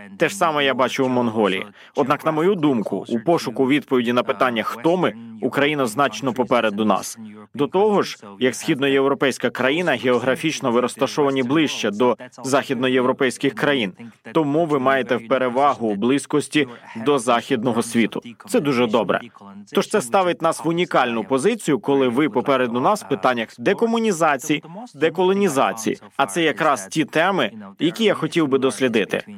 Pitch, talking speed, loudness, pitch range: 135 Hz, 145 wpm, -20 LUFS, 125-160 Hz